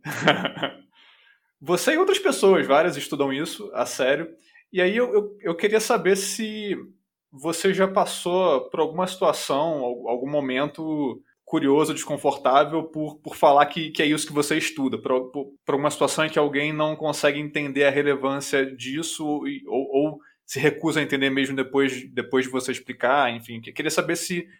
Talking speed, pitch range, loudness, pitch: 165 wpm, 140-175 Hz, -23 LUFS, 150 Hz